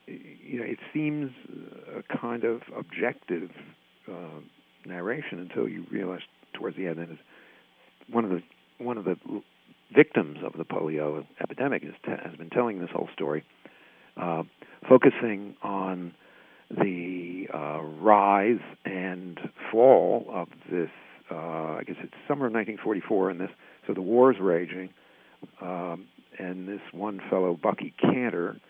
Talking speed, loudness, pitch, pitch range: 135 wpm, -28 LUFS, 90 Hz, 85-105 Hz